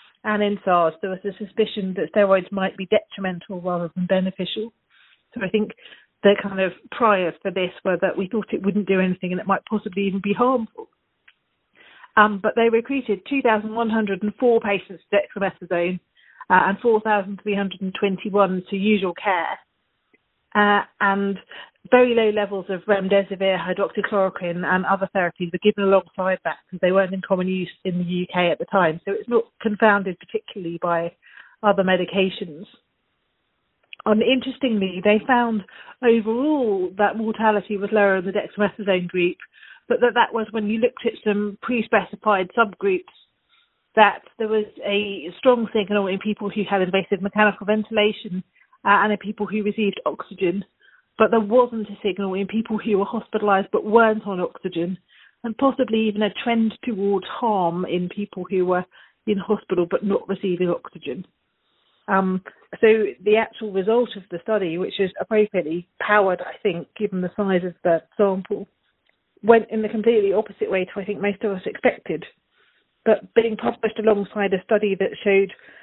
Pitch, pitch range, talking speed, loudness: 205 Hz, 190-220 Hz, 160 wpm, -21 LUFS